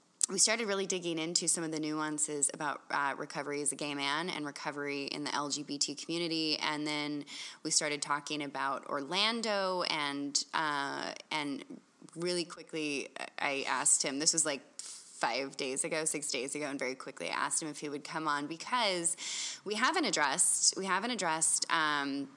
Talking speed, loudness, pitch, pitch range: 175 wpm, -32 LUFS, 155 Hz, 145-170 Hz